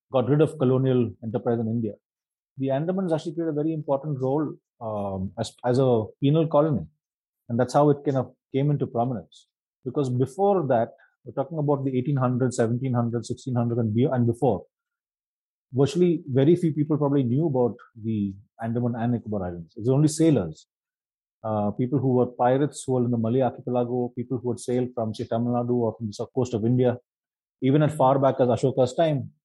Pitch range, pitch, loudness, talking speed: 120-145 Hz, 125 Hz, -25 LUFS, 185 wpm